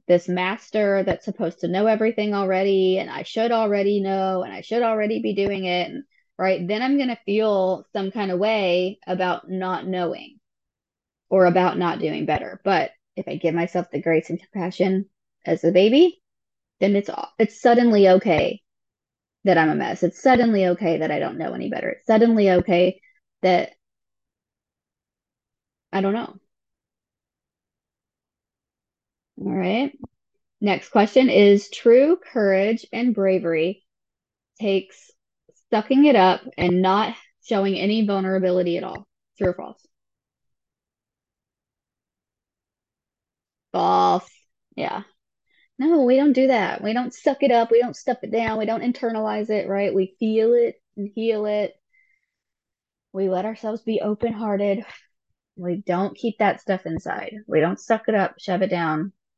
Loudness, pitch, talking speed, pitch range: -21 LUFS, 200 Hz, 150 wpm, 185-230 Hz